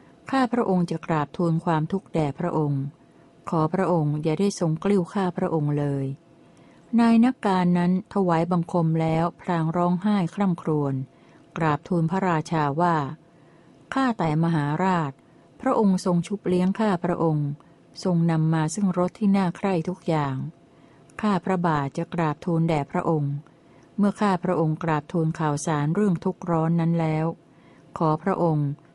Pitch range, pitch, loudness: 160-185 Hz, 170 Hz, -24 LUFS